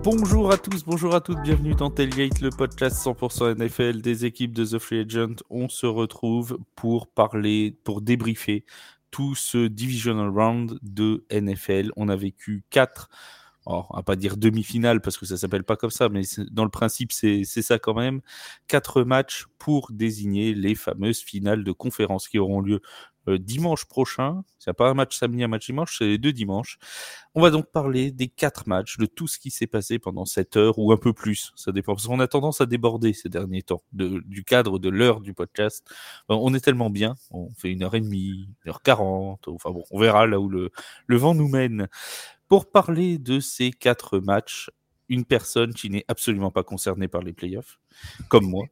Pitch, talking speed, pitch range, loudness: 115 Hz, 200 wpm, 100-125 Hz, -24 LUFS